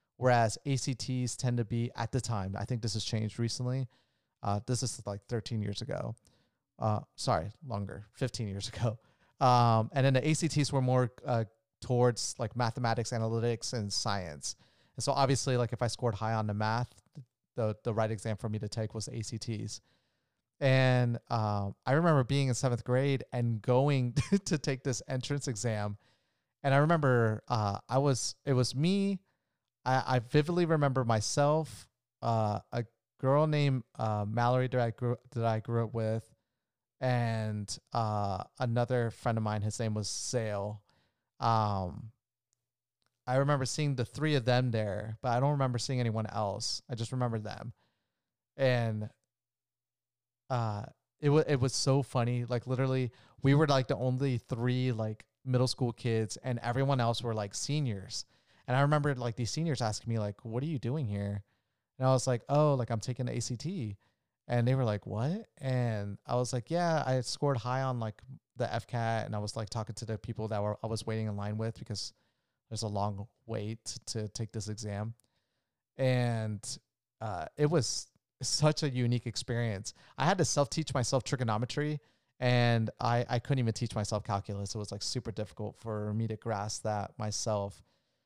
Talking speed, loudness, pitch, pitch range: 175 wpm, -32 LUFS, 120 Hz, 110-130 Hz